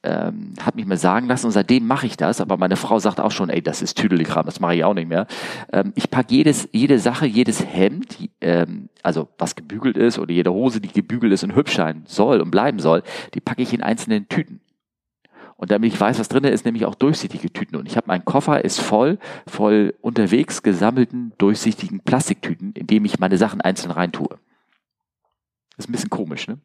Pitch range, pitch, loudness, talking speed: 105-130 Hz, 115 Hz, -19 LUFS, 215 wpm